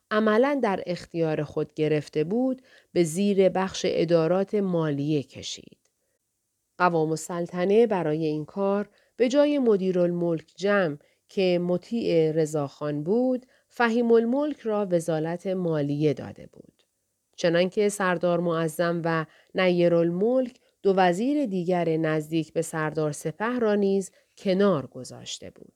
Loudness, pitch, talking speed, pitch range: -25 LUFS, 180 Hz, 120 wpm, 160-210 Hz